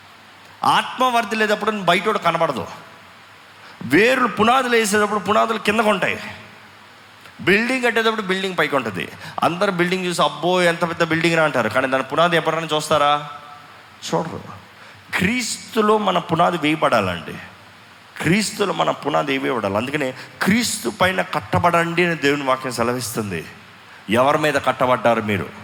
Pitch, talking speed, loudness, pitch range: 170 Hz, 115 wpm, -19 LUFS, 145-210 Hz